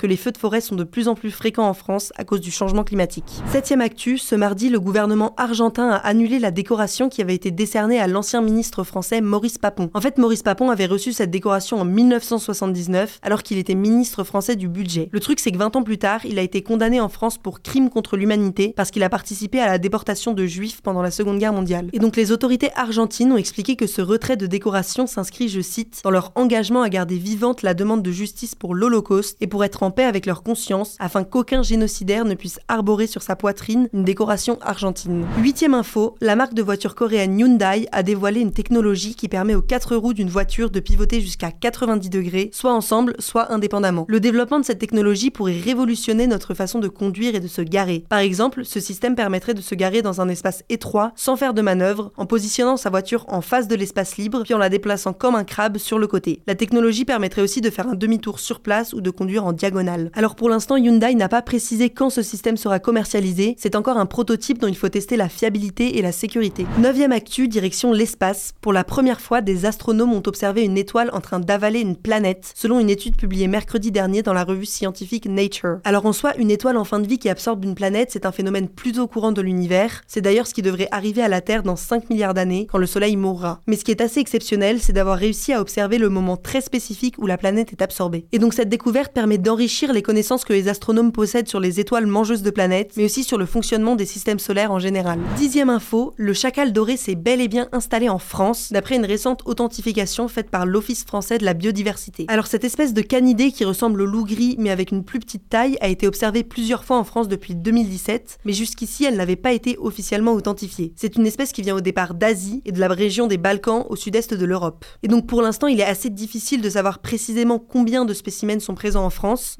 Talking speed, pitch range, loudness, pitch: 230 wpm, 195-235 Hz, -20 LUFS, 215 Hz